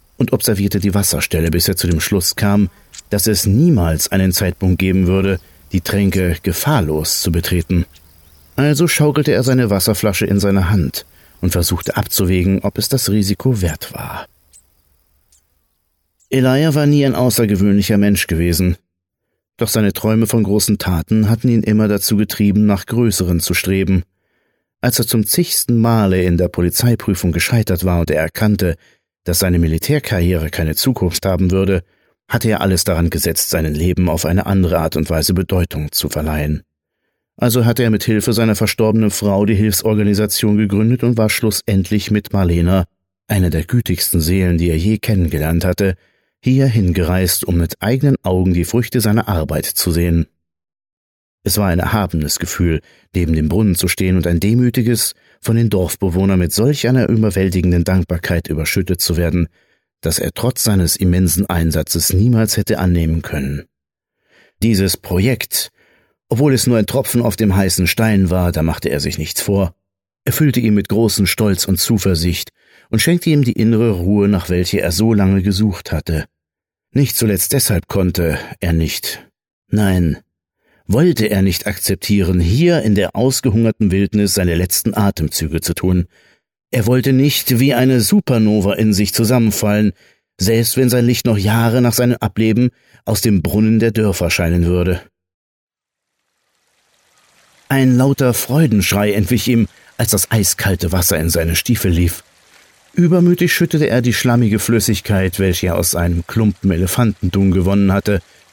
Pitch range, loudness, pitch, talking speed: 85-110 Hz, -15 LUFS, 100 Hz, 155 wpm